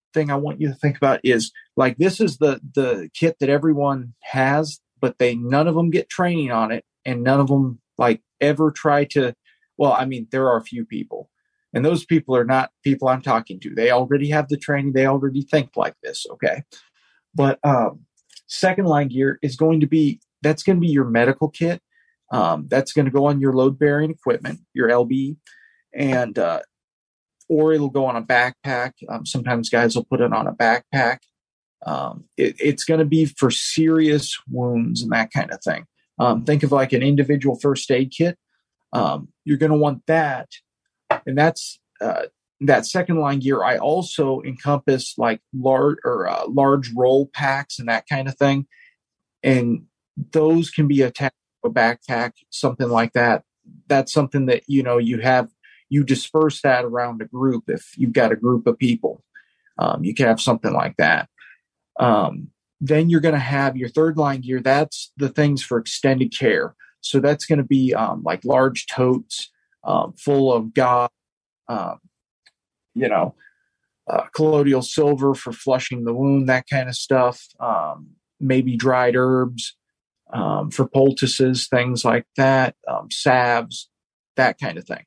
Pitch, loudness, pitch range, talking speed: 135 Hz, -20 LUFS, 125-150 Hz, 180 wpm